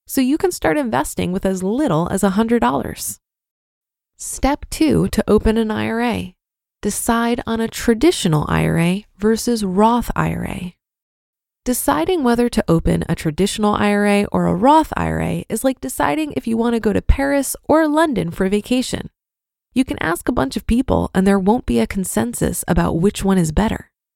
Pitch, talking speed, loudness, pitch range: 215 Hz, 165 wpm, -18 LUFS, 190-245 Hz